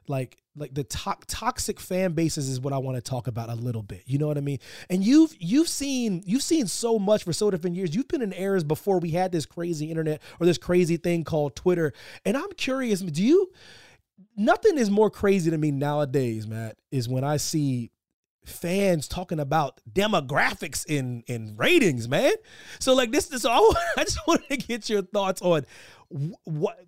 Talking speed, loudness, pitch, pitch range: 200 wpm, -25 LUFS, 175 Hz, 145-215 Hz